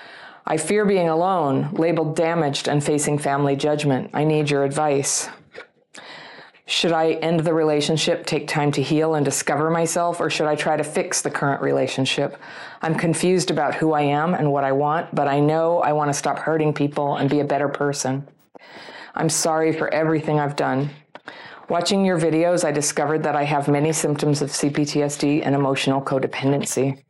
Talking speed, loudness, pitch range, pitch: 175 wpm, -21 LUFS, 145-160 Hz, 150 Hz